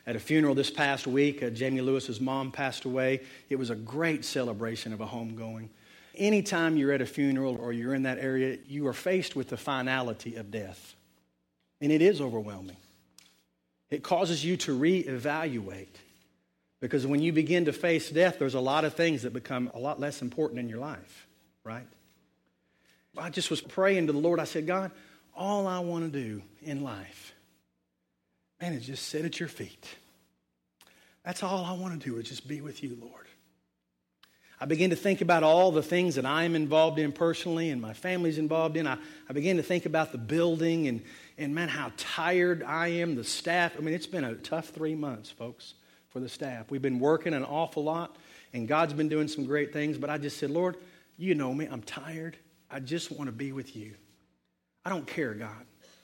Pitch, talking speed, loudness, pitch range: 140 Hz, 200 wpm, -30 LUFS, 115-160 Hz